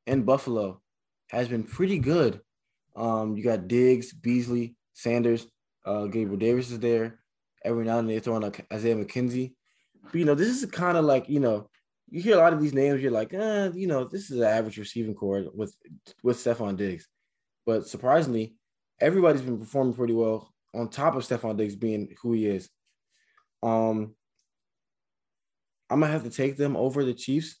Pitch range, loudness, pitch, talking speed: 110-135 Hz, -27 LUFS, 120 Hz, 185 wpm